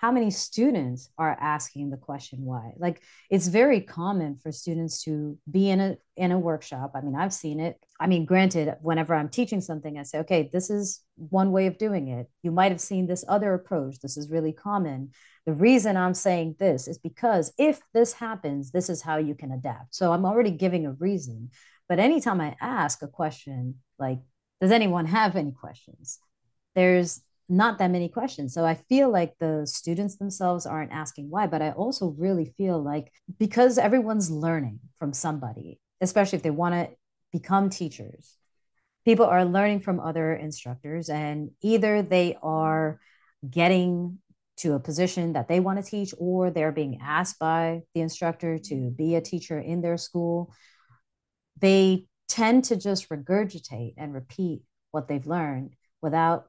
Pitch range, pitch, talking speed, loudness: 150-190 Hz, 170 Hz, 175 wpm, -26 LUFS